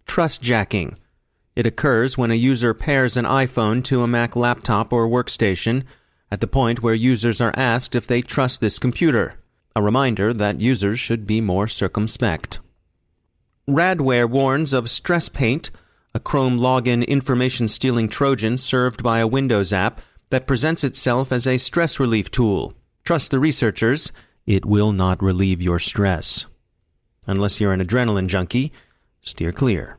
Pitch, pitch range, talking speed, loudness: 115 Hz, 105-130 Hz, 150 wpm, -19 LUFS